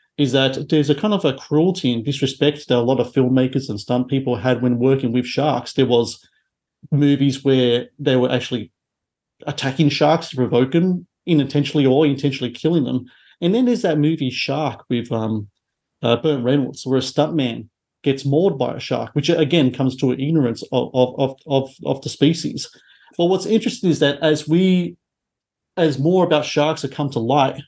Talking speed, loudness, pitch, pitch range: 195 wpm, -19 LUFS, 140 Hz, 125-155 Hz